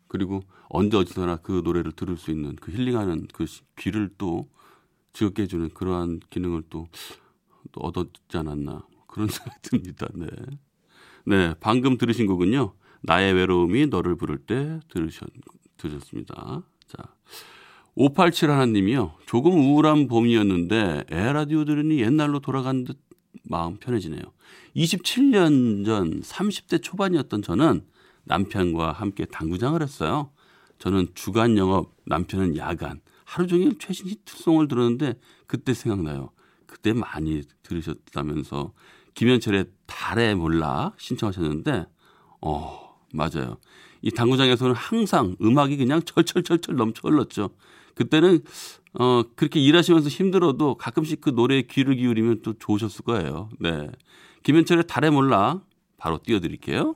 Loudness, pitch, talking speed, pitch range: -23 LUFS, 115 Hz, 295 characters per minute, 90-150 Hz